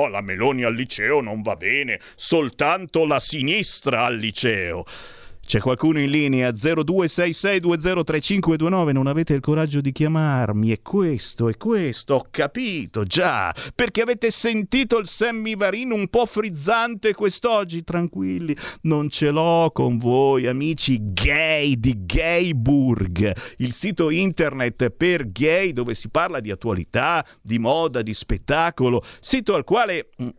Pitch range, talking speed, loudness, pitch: 125-185 Hz, 130 wpm, -21 LUFS, 155 Hz